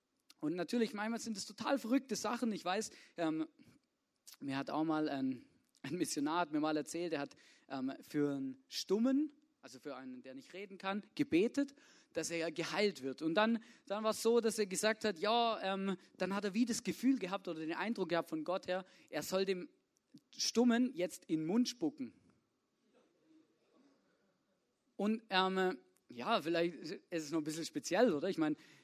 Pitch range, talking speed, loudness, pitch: 160-230 Hz, 185 wpm, -37 LUFS, 190 Hz